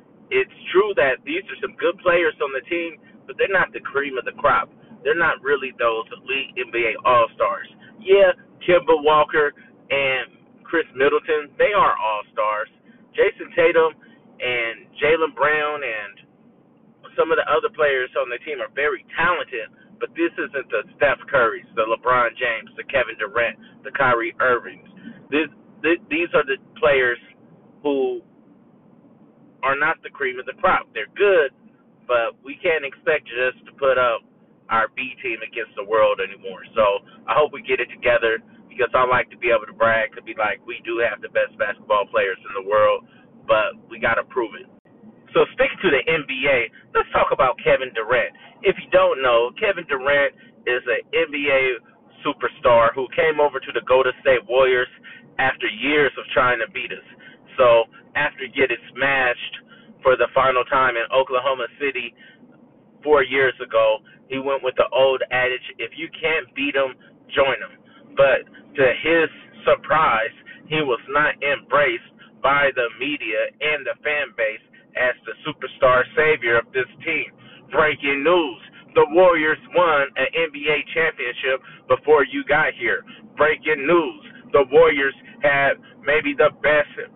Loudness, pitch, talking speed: -20 LUFS, 205 Hz, 160 wpm